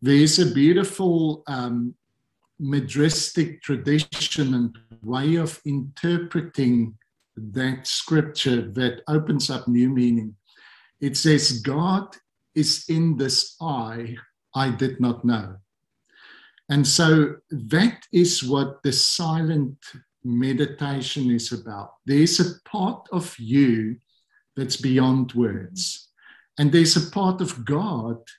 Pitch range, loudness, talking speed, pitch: 125-160 Hz, -22 LUFS, 110 wpm, 140 Hz